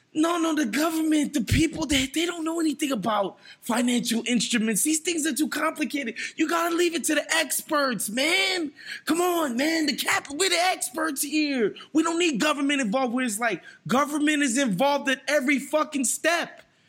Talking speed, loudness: 180 wpm, -24 LUFS